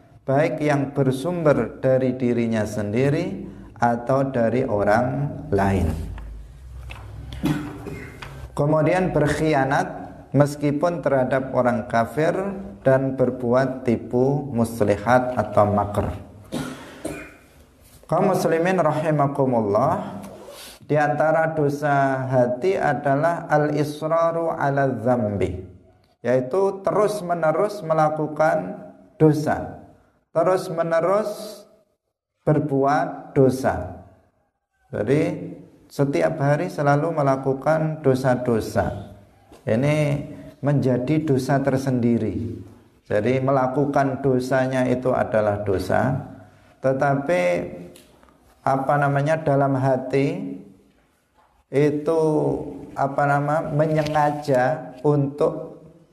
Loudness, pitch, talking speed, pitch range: -22 LUFS, 135 Hz, 70 wpm, 120-150 Hz